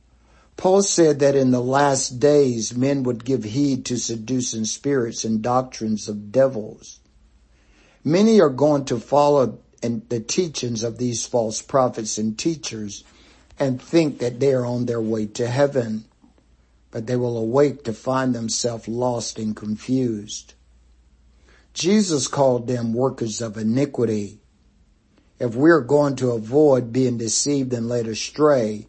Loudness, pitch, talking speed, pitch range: -21 LUFS, 120 Hz, 140 wpm, 110-135 Hz